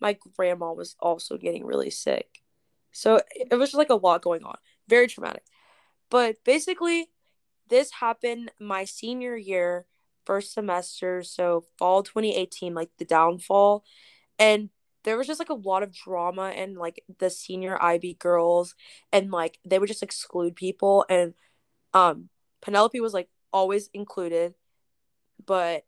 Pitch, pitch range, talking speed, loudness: 190 Hz, 175-220 Hz, 145 wpm, -25 LUFS